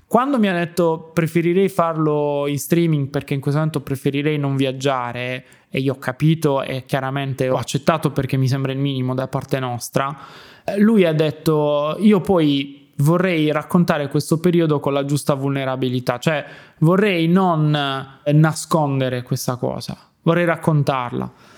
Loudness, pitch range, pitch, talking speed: -19 LUFS, 135-165 Hz, 145 Hz, 145 wpm